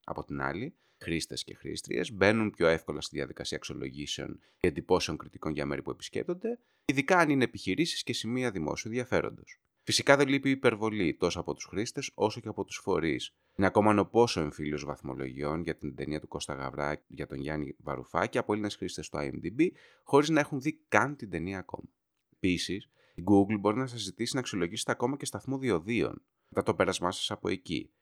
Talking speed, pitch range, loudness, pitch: 190 wpm, 75-125 Hz, -31 LUFS, 100 Hz